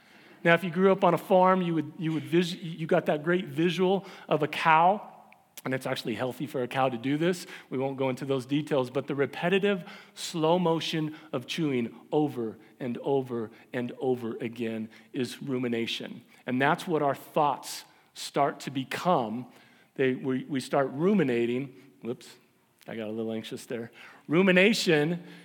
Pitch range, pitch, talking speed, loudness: 130-175 Hz, 145 Hz, 170 wpm, -28 LUFS